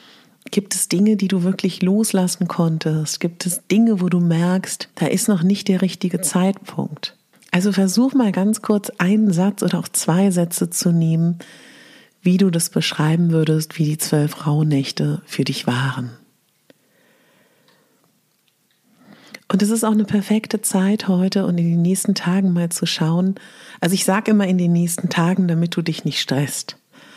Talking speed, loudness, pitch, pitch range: 170 wpm, -19 LUFS, 185 Hz, 170-205 Hz